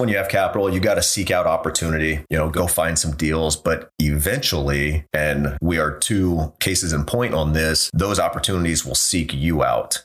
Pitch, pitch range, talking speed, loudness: 80 Hz, 75-90 Hz, 195 wpm, -20 LUFS